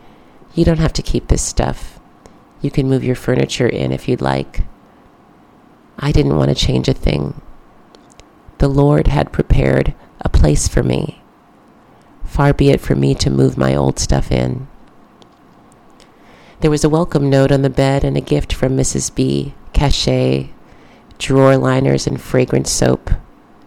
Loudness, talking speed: -16 LUFS, 155 wpm